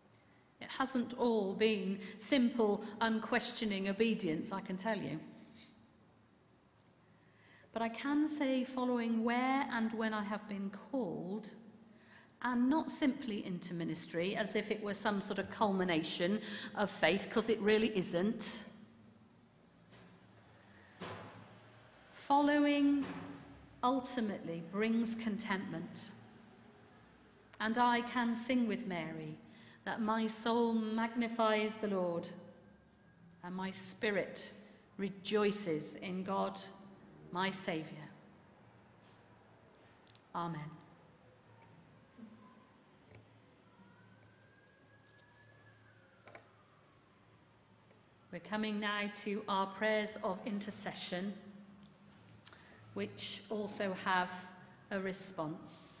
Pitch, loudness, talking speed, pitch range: 205 Hz, -36 LUFS, 85 wpm, 170-225 Hz